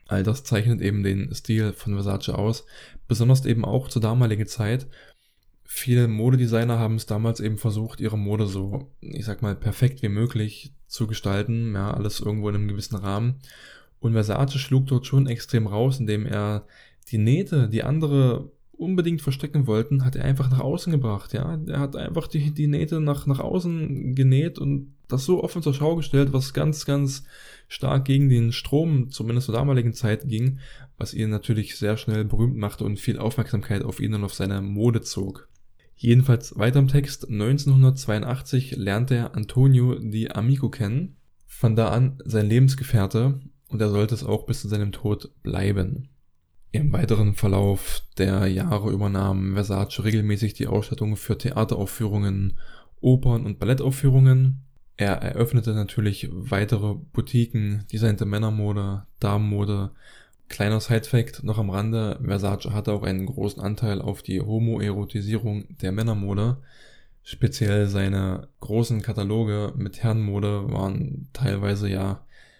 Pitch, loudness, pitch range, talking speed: 115 Hz, -24 LUFS, 105-135 Hz, 150 wpm